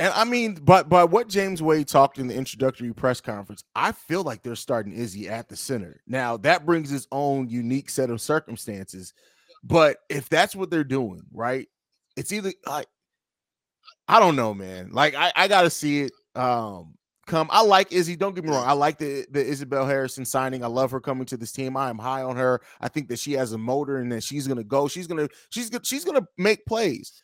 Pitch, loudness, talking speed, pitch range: 135 Hz, -23 LUFS, 220 wpm, 120-170 Hz